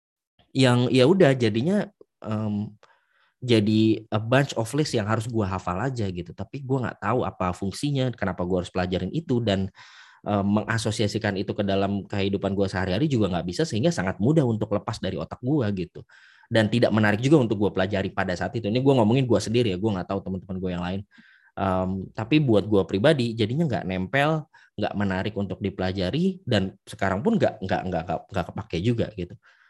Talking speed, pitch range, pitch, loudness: 190 wpm, 95-125 Hz, 105 Hz, -24 LUFS